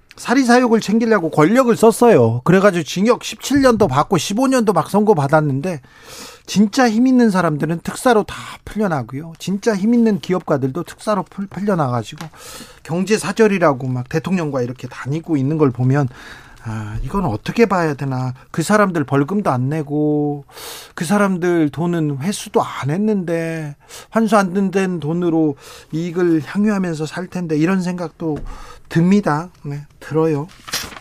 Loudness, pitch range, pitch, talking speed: -17 LUFS, 150-205 Hz, 170 Hz, 305 characters per minute